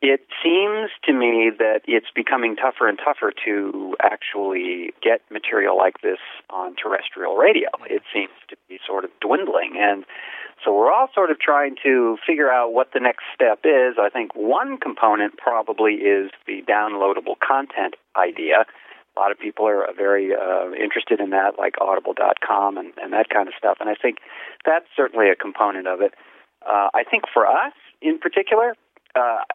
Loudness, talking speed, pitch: -20 LUFS, 175 wpm, 135 Hz